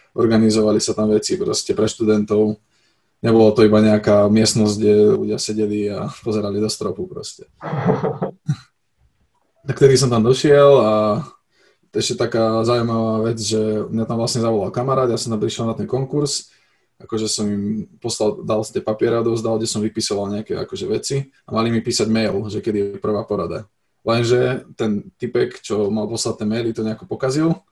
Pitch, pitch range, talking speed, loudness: 110 Hz, 105-120 Hz, 175 wpm, -19 LUFS